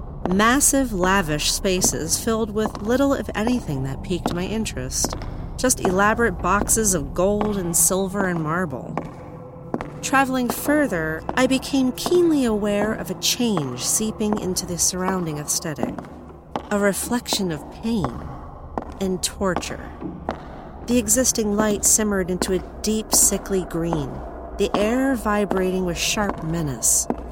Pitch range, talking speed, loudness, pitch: 185-230 Hz, 125 wpm, -21 LUFS, 205 Hz